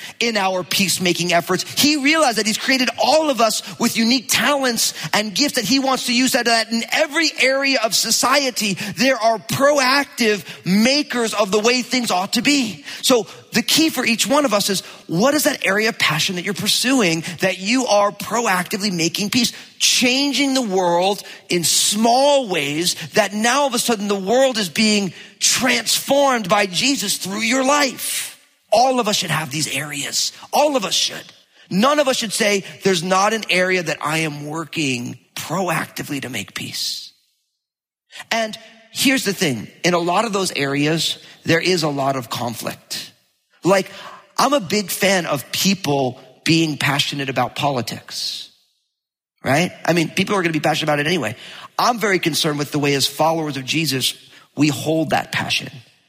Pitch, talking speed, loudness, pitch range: 200 Hz, 180 wpm, -18 LUFS, 165-245 Hz